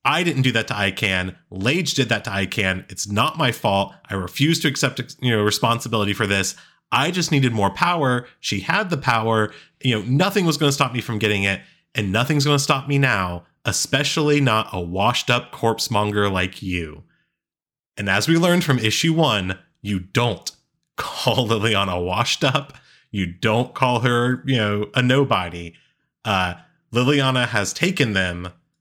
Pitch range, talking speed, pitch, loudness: 100-140 Hz, 175 wpm, 115 Hz, -20 LUFS